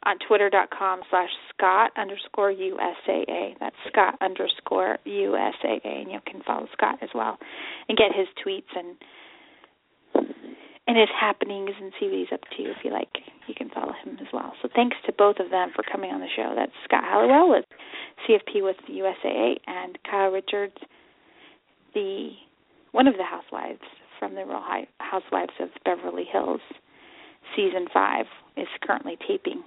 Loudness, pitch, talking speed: -25 LUFS, 220 Hz, 160 wpm